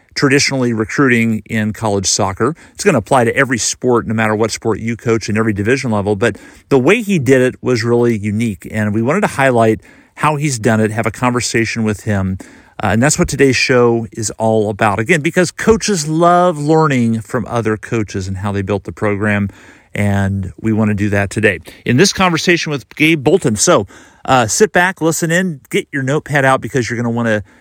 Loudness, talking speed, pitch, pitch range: -14 LUFS, 210 wpm, 115 Hz, 110-140 Hz